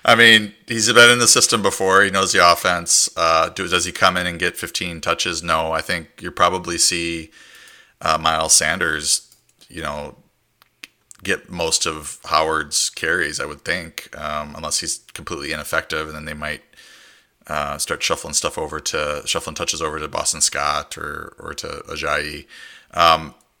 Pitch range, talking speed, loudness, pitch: 80-115 Hz, 170 wpm, -18 LUFS, 85 Hz